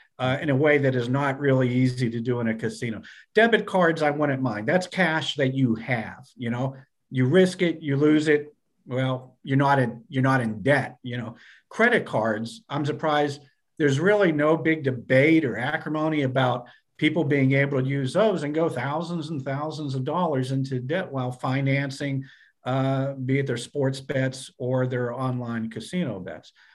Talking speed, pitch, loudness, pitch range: 185 wpm, 135 Hz, -24 LUFS, 125-150 Hz